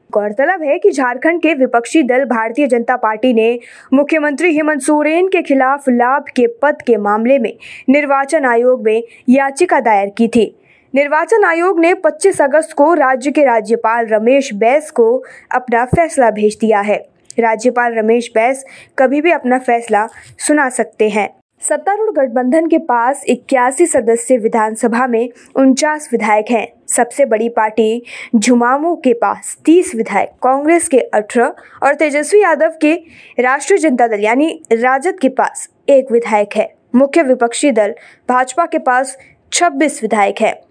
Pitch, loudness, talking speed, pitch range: 260 Hz, -13 LUFS, 150 wpm, 230-305 Hz